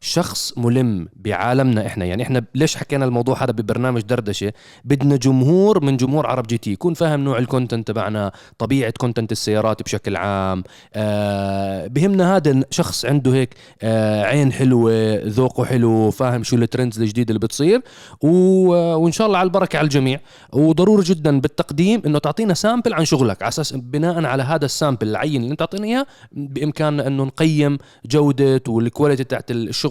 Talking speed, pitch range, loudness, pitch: 155 wpm, 115-150 Hz, -18 LUFS, 130 Hz